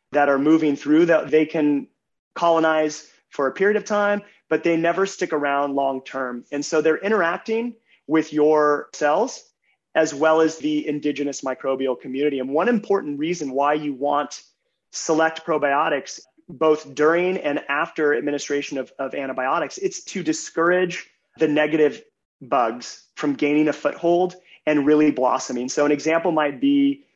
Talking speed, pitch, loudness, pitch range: 150 wpm, 155 Hz, -21 LUFS, 145-170 Hz